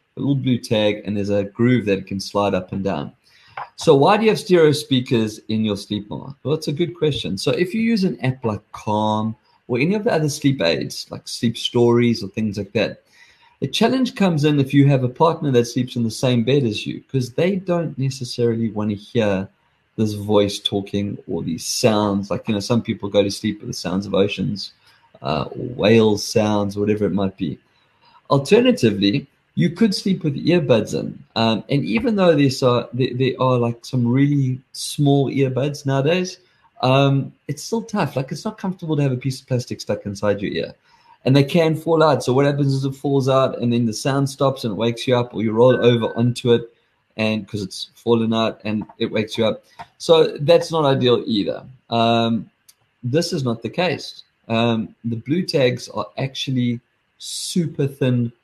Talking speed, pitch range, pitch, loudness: 200 wpm, 110-145 Hz, 125 Hz, -20 LUFS